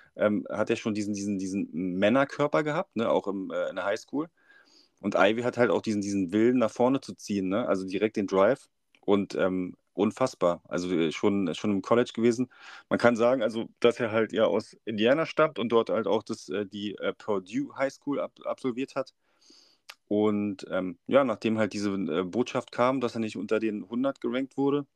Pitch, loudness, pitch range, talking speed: 110 Hz, -28 LUFS, 100-125 Hz, 210 wpm